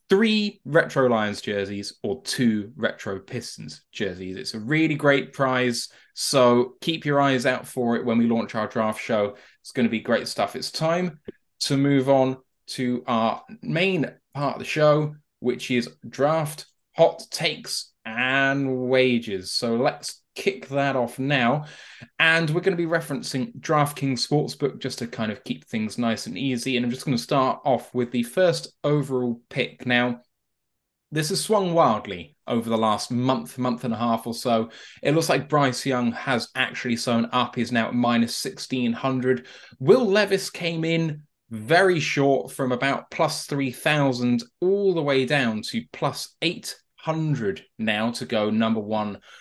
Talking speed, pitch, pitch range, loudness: 170 wpm, 130 Hz, 115-150 Hz, -24 LUFS